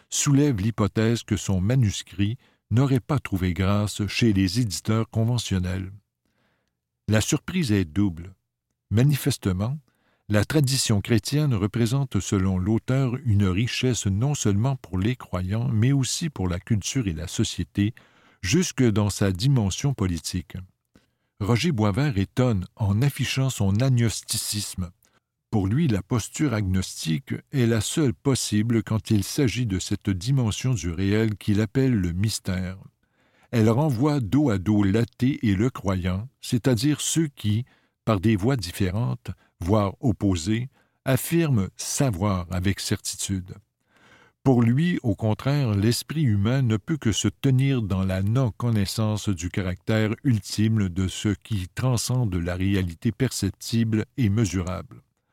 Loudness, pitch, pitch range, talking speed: -24 LUFS, 110 Hz, 100-125 Hz, 130 wpm